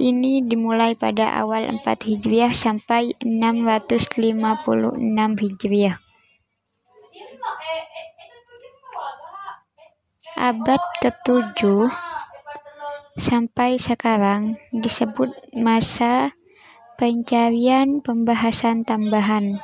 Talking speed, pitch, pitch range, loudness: 55 wpm, 235 Hz, 225-290 Hz, -20 LUFS